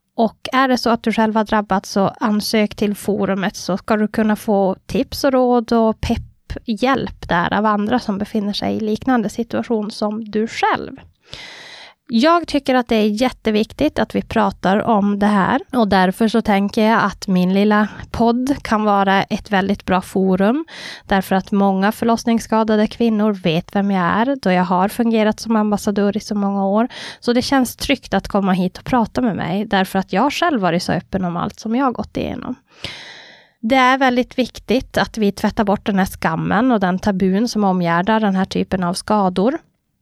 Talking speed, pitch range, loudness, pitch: 190 wpm, 195-235 Hz, -18 LUFS, 215 Hz